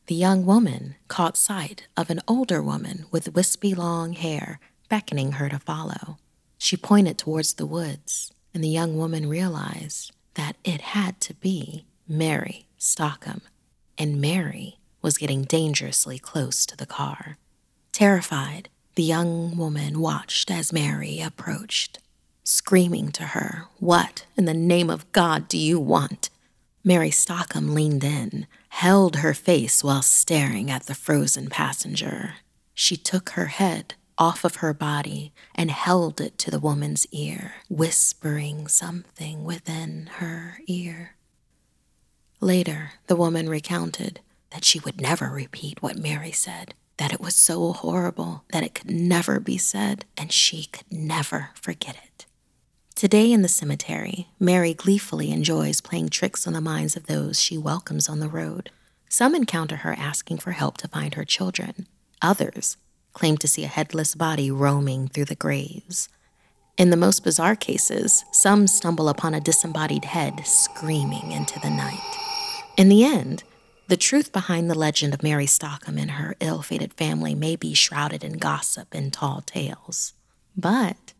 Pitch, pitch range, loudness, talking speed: 160 Hz, 145-180 Hz, -22 LUFS, 150 wpm